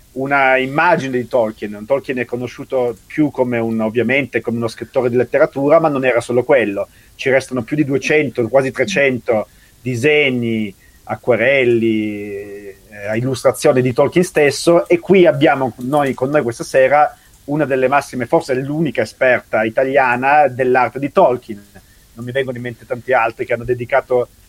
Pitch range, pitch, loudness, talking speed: 120-140 Hz, 130 Hz, -16 LUFS, 155 wpm